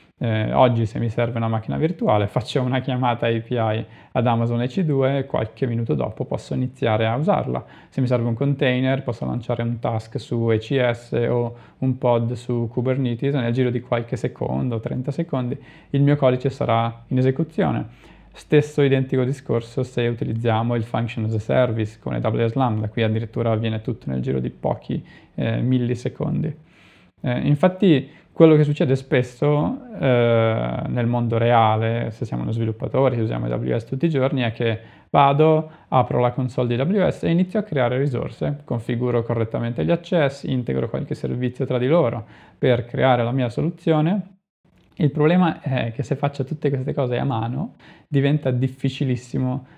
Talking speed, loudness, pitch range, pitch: 165 wpm, -22 LUFS, 115-140 Hz, 125 Hz